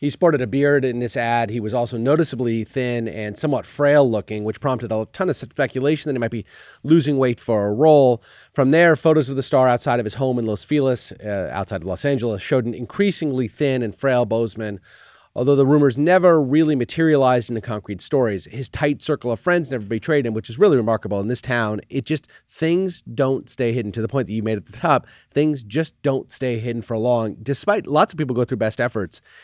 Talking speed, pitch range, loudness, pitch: 220 wpm, 115-145 Hz, -20 LUFS, 125 Hz